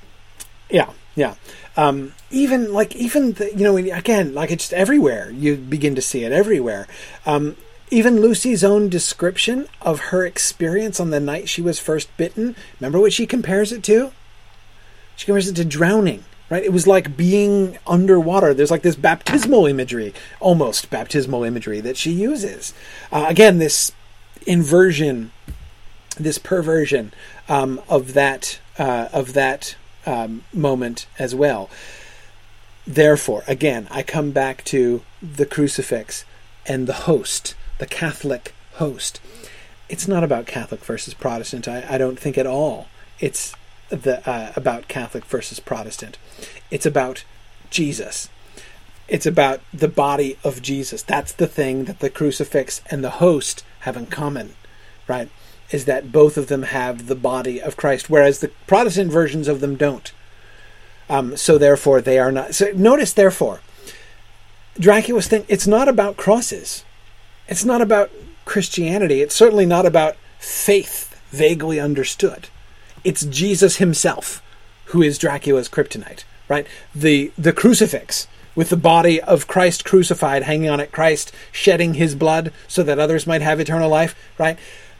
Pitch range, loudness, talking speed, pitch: 130-190 Hz, -18 LUFS, 145 wpm, 155 Hz